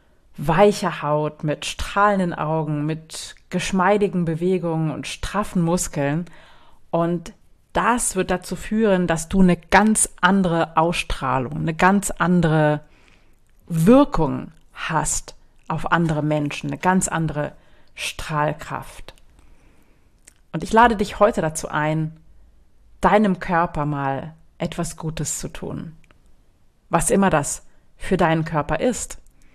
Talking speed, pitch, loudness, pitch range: 110 wpm, 165 Hz, -21 LUFS, 150-185 Hz